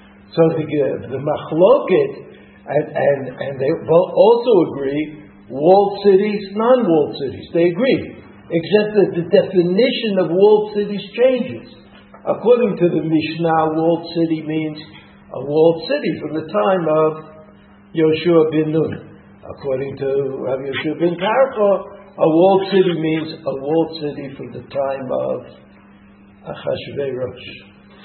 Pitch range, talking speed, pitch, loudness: 145-200 Hz, 125 wpm, 165 Hz, -17 LUFS